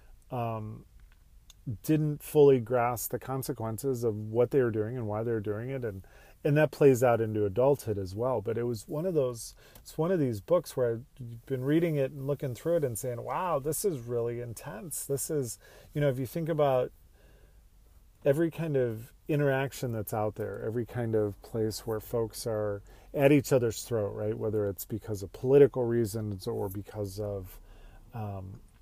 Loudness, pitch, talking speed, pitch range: -30 LUFS, 120 Hz, 185 wpm, 105-140 Hz